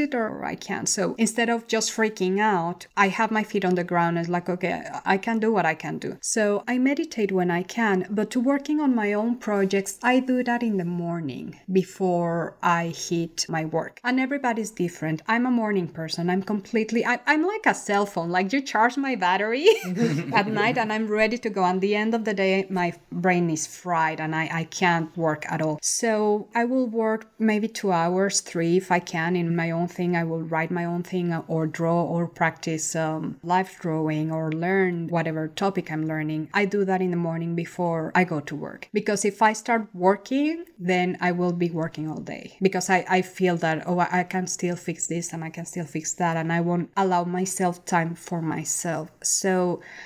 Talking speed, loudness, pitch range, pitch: 210 wpm, -24 LUFS, 170-215 Hz, 180 Hz